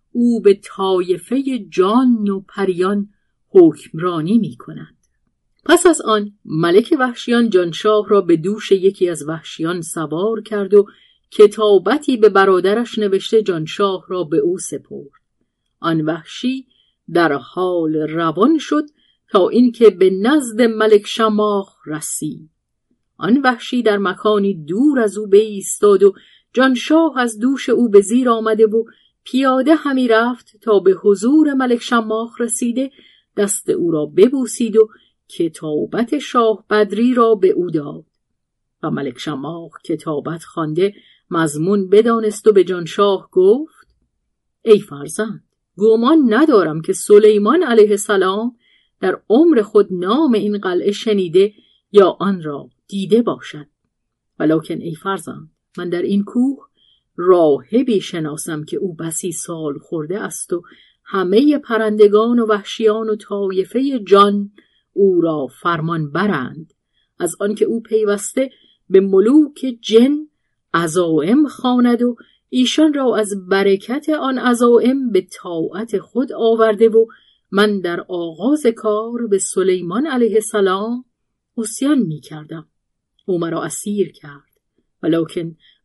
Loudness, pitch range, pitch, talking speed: -16 LUFS, 185-240 Hz, 210 Hz, 125 wpm